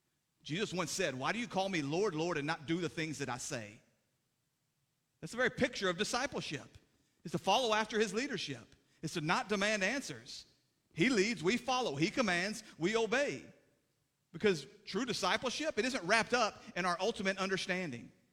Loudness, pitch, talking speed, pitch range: -35 LUFS, 185 Hz, 175 wpm, 150-215 Hz